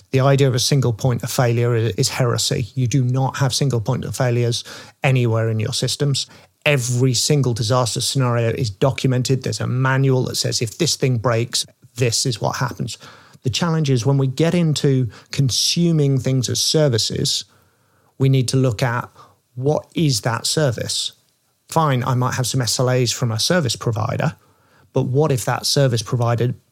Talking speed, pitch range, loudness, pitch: 175 wpm, 120-135 Hz, -19 LUFS, 130 Hz